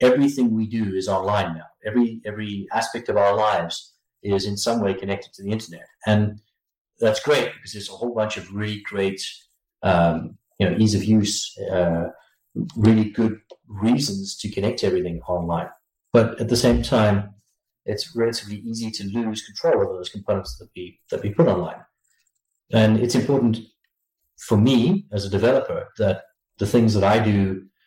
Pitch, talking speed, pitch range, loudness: 105 Hz, 170 wpm, 95-115 Hz, -22 LUFS